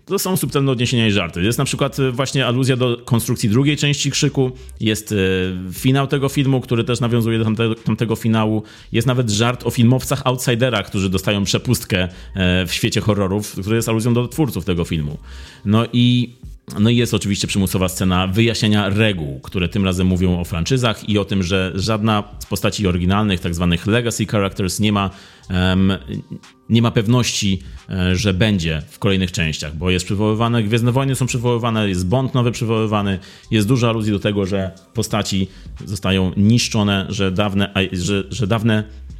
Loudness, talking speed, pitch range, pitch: -18 LUFS, 170 wpm, 95-120 Hz, 105 Hz